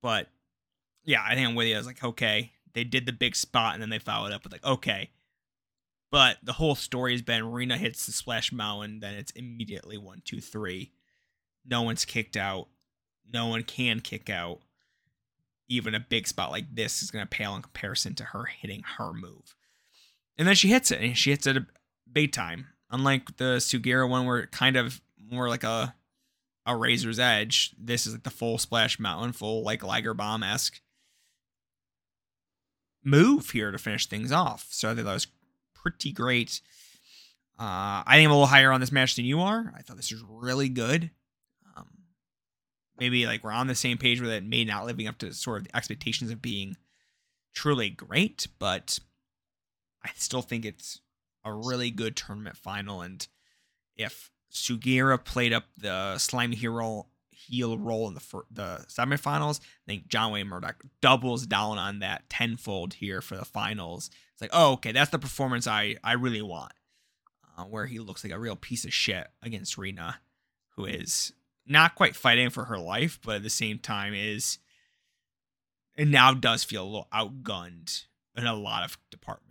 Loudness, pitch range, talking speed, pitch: -27 LUFS, 105-130 Hz, 185 wpm, 115 Hz